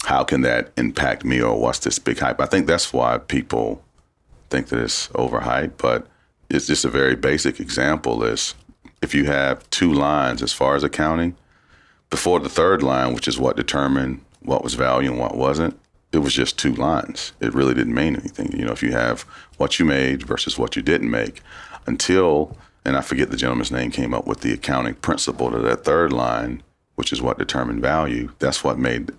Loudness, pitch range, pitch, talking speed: -21 LUFS, 60-70 Hz, 65 Hz, 200 wpm